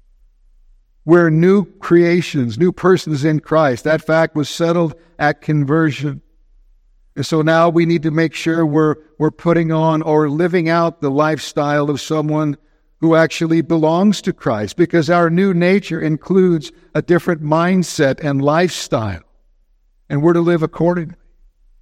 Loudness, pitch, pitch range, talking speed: -16 LUFS, 160 Hz, 145-170 Hz, 145 wpm